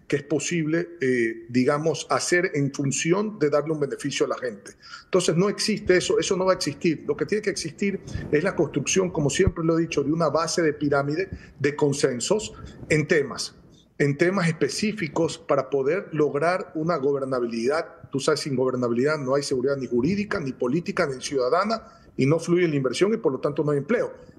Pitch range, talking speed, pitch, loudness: 140-175 Hz, 195 wpm, 155 Hz, -24 LUFS